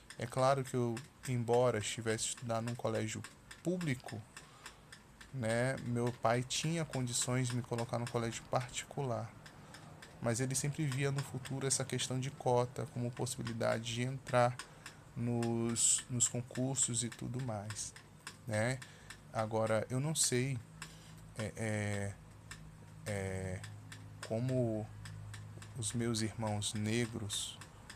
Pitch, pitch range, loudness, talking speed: 120 Hz, 110-130 Hz, -36 LUFS, 115 wpm